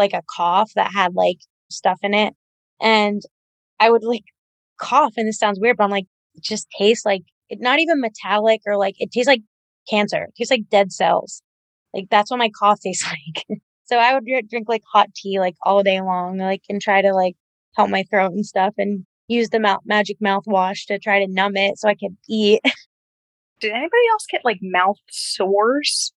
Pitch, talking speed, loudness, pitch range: 205 Hz, 205 wpm, -19 LUFS, 195-225 Hz